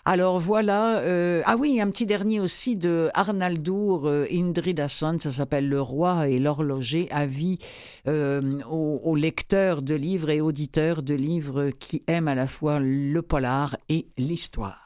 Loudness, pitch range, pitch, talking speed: -25 LUFS, 145-180 Hz, 155 Hz, 160 wpm